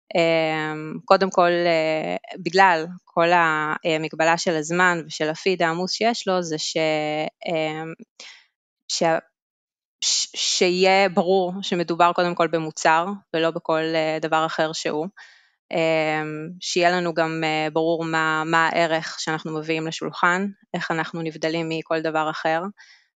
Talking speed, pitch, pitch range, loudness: 120 wpm, 165 Hz, 160-180 Hz, -22 LUFS